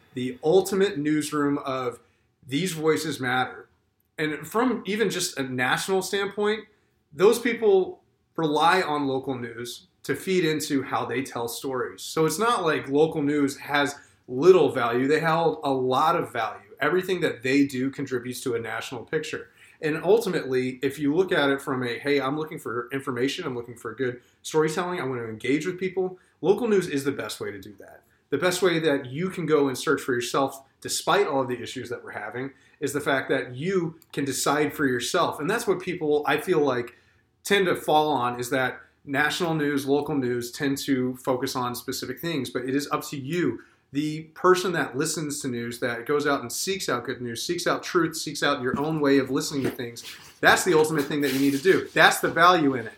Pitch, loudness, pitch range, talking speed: 140 Hz, -25 LUFS, 130-160 Hz, 205 wpm